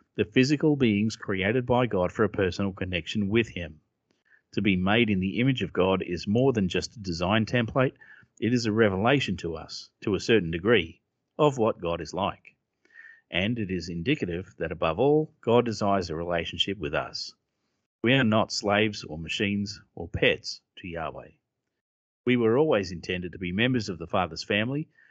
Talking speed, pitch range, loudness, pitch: 180 wpm, 90-120 Hz, -26 LUFS, 100 Hz